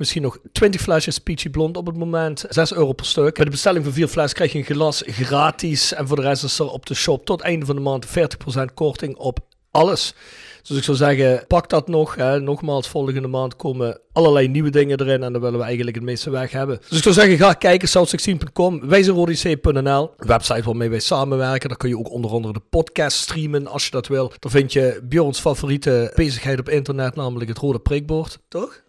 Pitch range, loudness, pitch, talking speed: 130-160 Hz, -19 LUFS, 145 Hz, 220 wpm